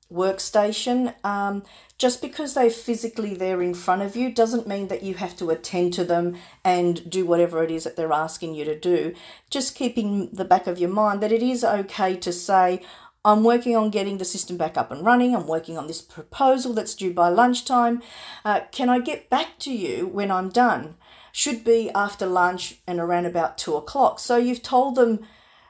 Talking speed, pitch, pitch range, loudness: 200 wpm, 200 Hz, 175-240 Hz, -23 LUFS